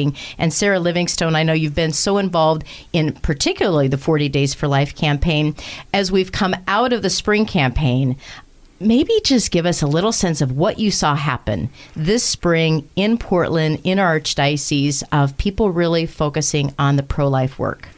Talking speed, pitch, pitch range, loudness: 175 wpm, 160 Hz, 145-190 Hz, -18 LUFS